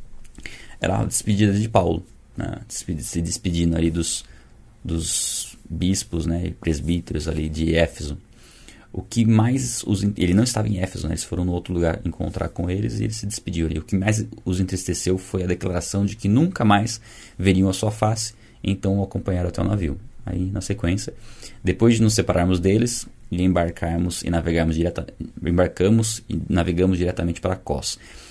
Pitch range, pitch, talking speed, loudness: 85-105 Hz, 95 Hz, 170 wpm, -22 LUFS